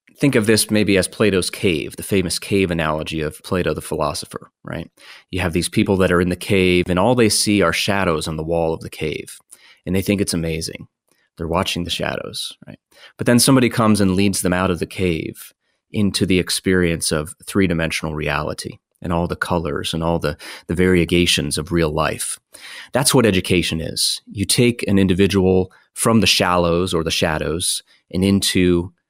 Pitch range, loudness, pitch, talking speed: 85-100 Hz, -18 LUFS, 90 Hz, 190 wpm